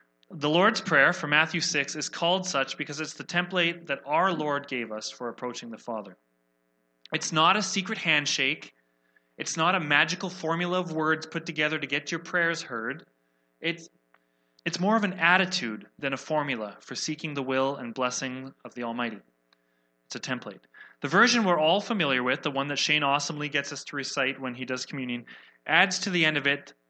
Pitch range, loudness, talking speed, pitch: 120-165 Hz, -27 LUFS, 195 wpm, 145 Hz